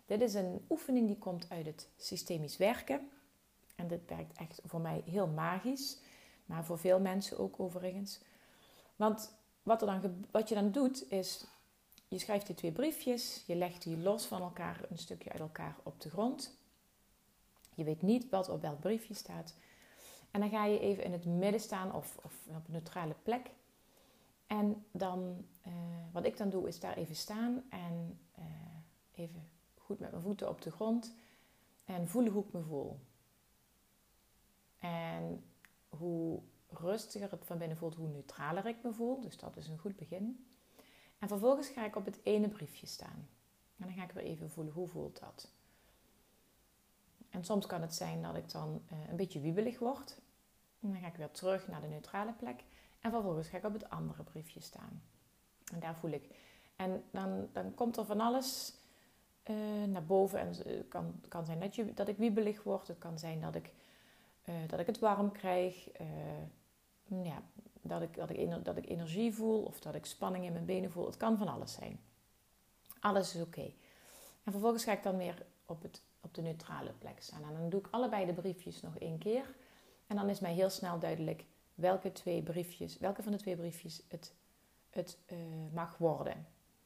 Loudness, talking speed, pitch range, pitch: -39 LUFS, 190 wpm, 170-215 Hz, 185 Hz